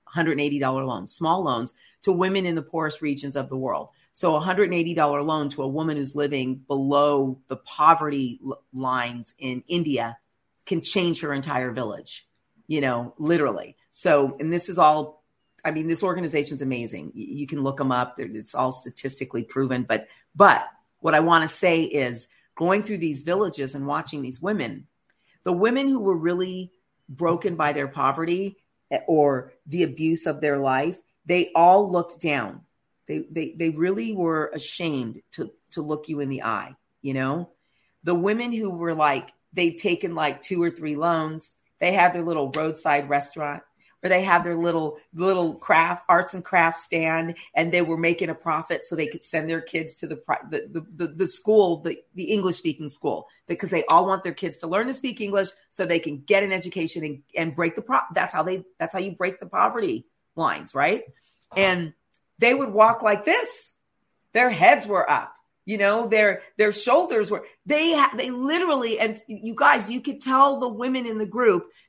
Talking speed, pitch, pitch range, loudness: 190 wpm, 165 Hz, 145-190 Hz, -23 LUFS